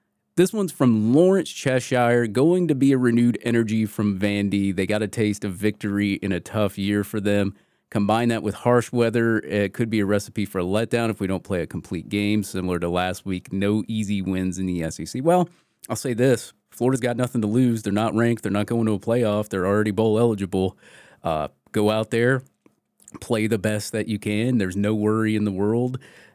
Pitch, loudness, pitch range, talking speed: 110 Hz, -23 LUFS, 100-120 Hz, 210 wpm